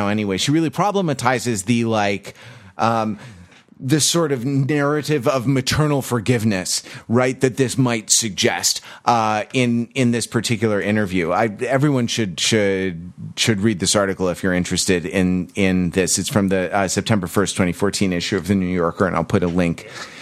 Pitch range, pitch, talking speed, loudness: 95-125 Hz, 110 Hz, 170 wpm, -19 LUFS